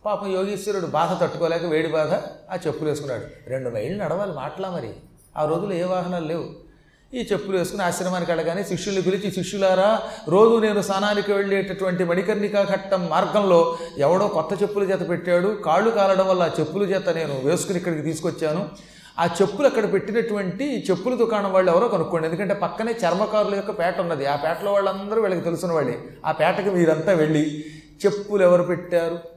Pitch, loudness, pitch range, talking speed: 185 Hz, -22 LUFS, 165-200 Hz, 155 wpm